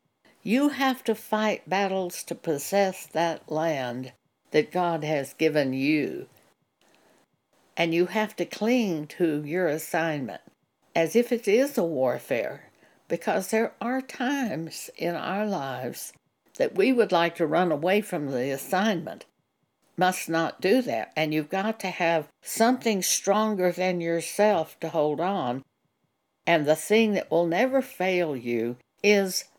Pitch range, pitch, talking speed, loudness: 160-215 Hz, 180 Hz, 140 wpm, -26 LUFS